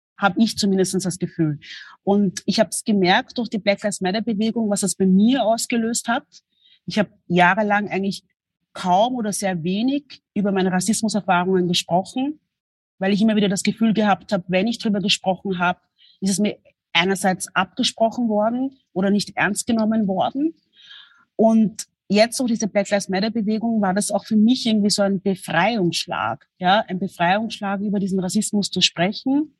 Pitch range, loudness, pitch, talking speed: 185-220 Hz, -20 LUFS, 205 Hz, 170 wpm